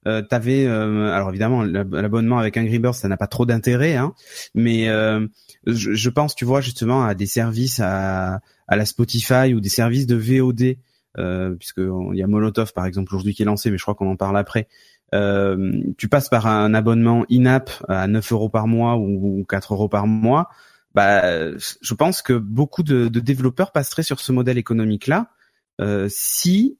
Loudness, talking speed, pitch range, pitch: -19 LUFS, 195 wpm, 105-125 Hz, 115 Hz